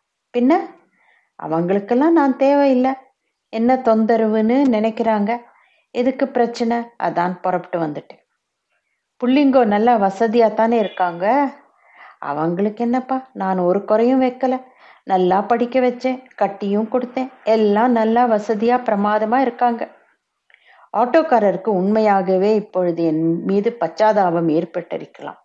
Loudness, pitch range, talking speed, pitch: -18 LUFS, 195-255 Hz, 90 wpm, 225 Hz